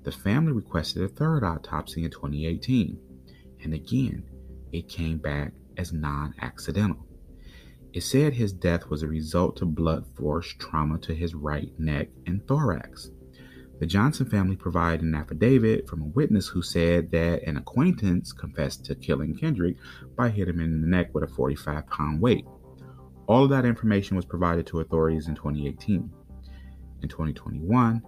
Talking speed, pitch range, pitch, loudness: 160 wpm, 70-90 Hz, 80 Hz, -27 LUFS